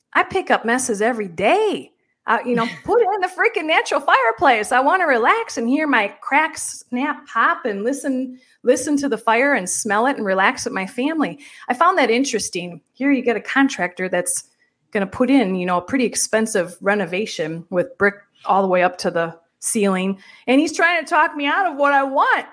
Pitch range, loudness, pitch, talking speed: 195-285 Hz, -19 LUFS, 245 Hz, 215 wpm